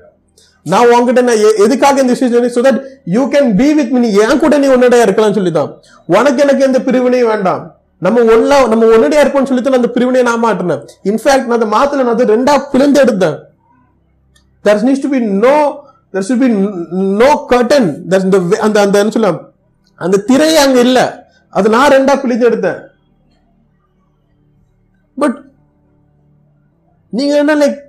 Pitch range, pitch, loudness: 210-275 Hz, 245 Hz, -10 LUFS